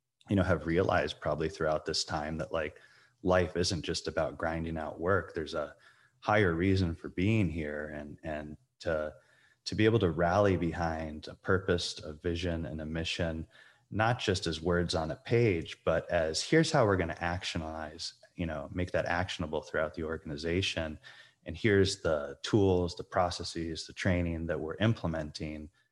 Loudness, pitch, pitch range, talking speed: -32 LUFS, 85 Hz, 80-95 Hz, 170 wpm